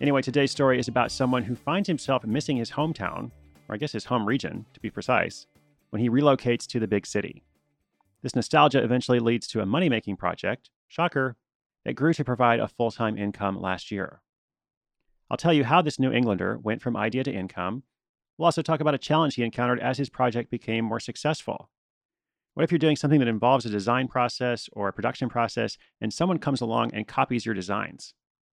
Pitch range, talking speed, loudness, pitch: 110-140 Hz, 200 wpm, -26 LUFS, 120 Hz